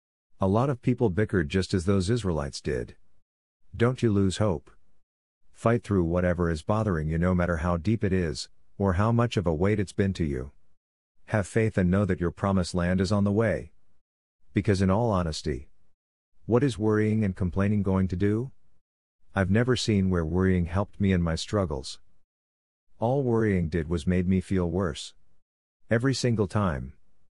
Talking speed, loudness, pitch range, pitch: 180 wpm, -26 LUFS, 85-105 Hz, 95 Hz